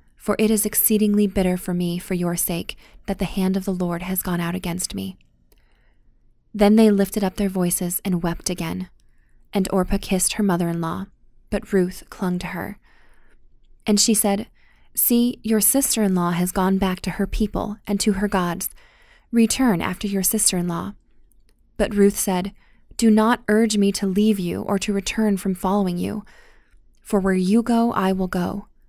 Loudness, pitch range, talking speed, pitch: -21 LUFS, 180-210 Hz, 185 wpm, 195 Hz